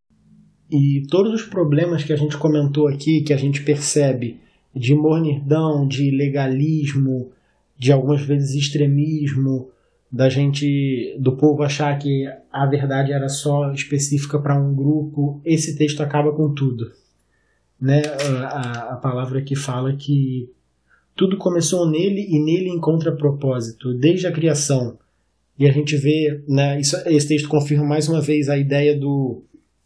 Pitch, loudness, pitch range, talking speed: 145 Hz, -19 LUFS, 135-150 Hz, 145 wpm